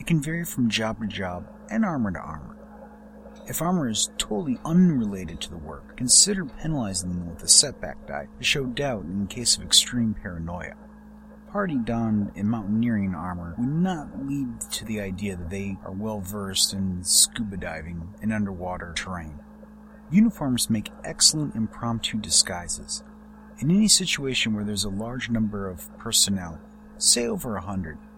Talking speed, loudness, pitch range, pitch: 160 wpm, -24 LUFS, 95-150 Hz, 110 Hz